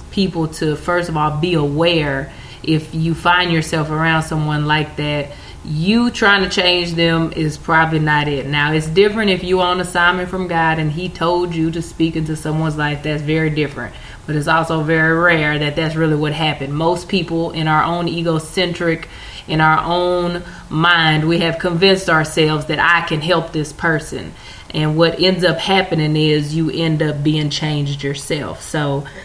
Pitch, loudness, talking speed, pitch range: 160 Hz, -16 LUFS, 180 wpm, 155-170 Hz